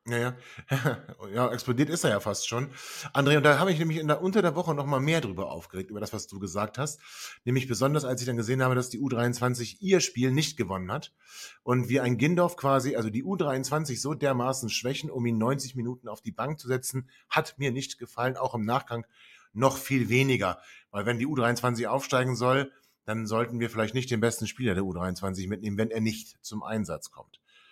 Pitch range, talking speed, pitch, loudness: 115-140 Hz, 215 wpm, 125 Hz, -28 LUFS